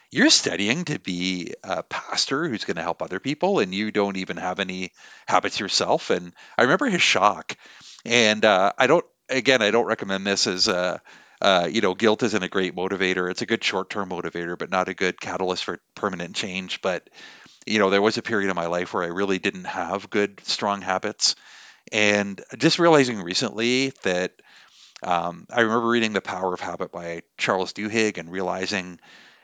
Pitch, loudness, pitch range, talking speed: 95 Hz, -23 LUFS, 90-110 Hz, 190 wpm